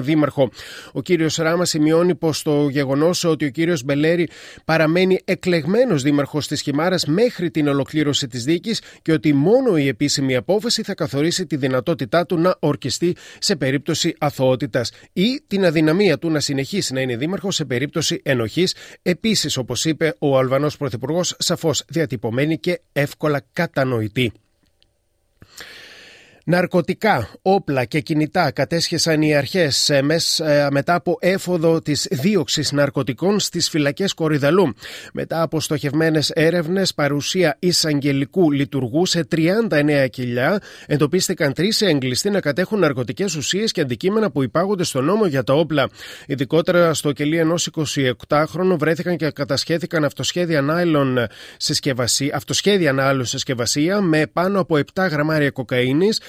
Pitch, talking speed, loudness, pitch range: 155 Hz, 130 wpm, -19 LUFS, 140-175 Hz